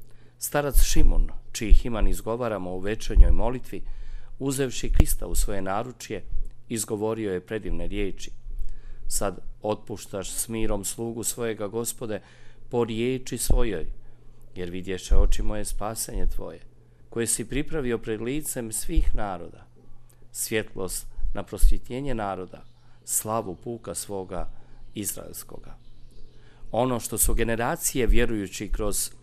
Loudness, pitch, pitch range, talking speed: -29 LUFS, 115 Hz, 100-120 Hz, 110 wpm